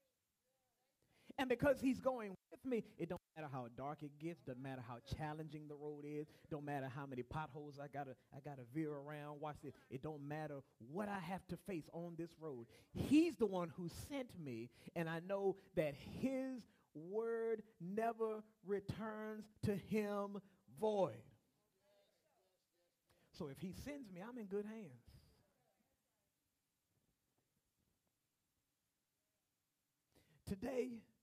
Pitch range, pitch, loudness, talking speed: 145-215 Hz, 170 Hz, -46 LUFS, 135 wpm